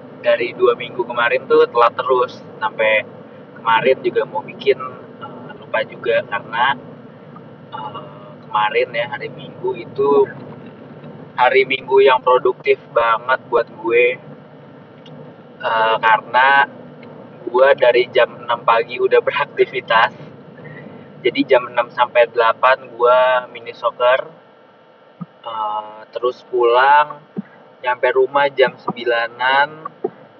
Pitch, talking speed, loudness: 125 Hz, 105 wpm, -16 LUFS